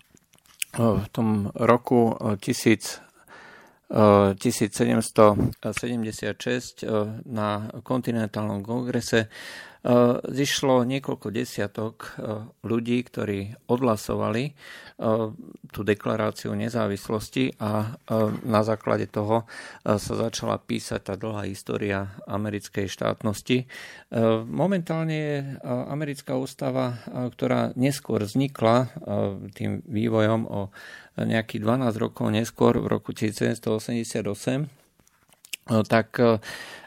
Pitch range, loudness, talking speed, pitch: 105-125 Hz, -25 LUFS, 75 wpm, 115 Hz